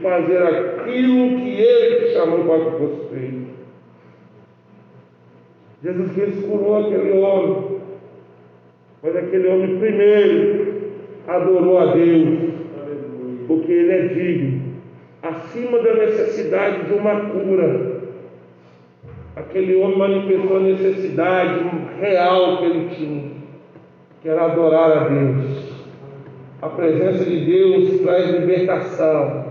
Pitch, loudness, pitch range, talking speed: 175 Hz, -17 LUFS, 145-195 Hz, 100 wpm